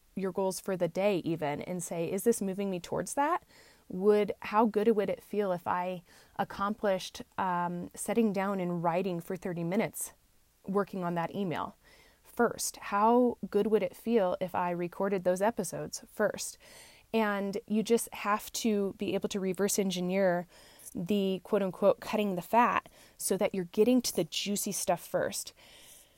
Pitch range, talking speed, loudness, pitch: 185-210 Hz, 165 wpm, -31 LUFS, 200 Hz